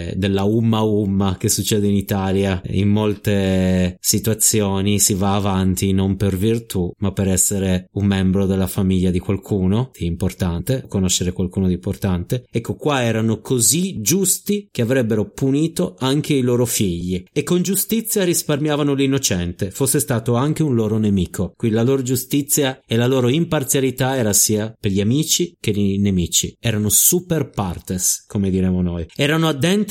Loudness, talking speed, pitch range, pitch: -18 LUFS, 155 wpm, 95-135 Hz, 105 Hz